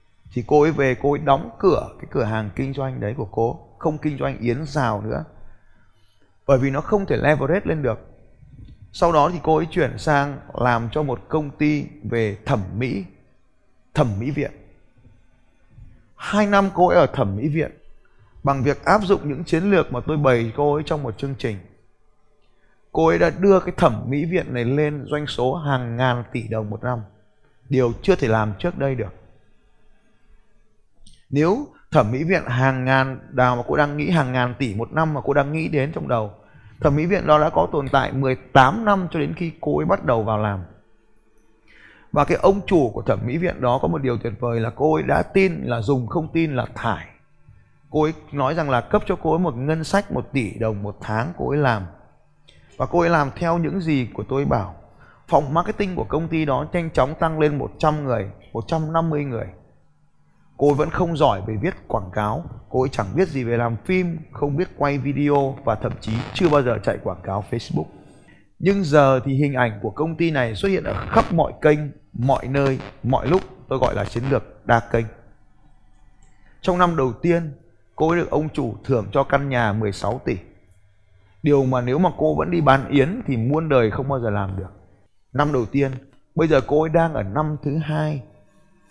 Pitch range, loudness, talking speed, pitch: 115-155 Hz, -21 LUFS, 210 wpm, 135 Hz